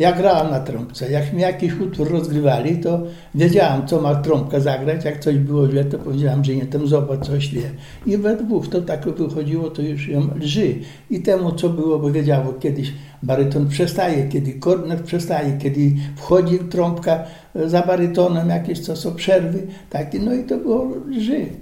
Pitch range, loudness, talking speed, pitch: 145-180 Hz, -19 LUFS, 180 wpm, 160 Hz